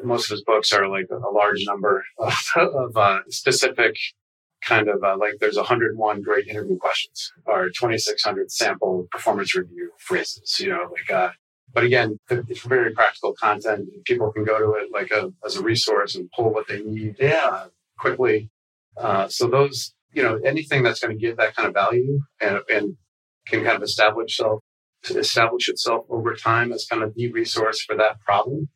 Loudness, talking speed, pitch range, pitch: -21 LUFS, 185 wpm, 110-140 Hz, 115 Hz